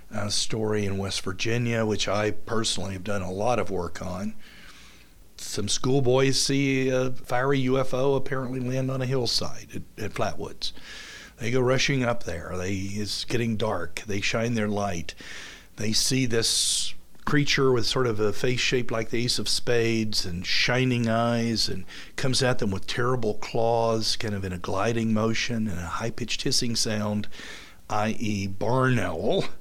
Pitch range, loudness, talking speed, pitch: 100-125 Hz, -26 LUFS, 165 wpm, 115 Hz